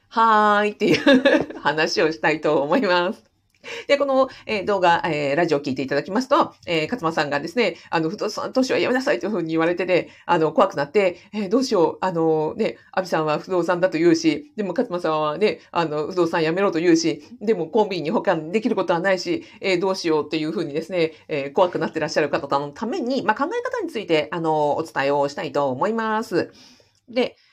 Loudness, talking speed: -21 LUFS, 395 characters per minute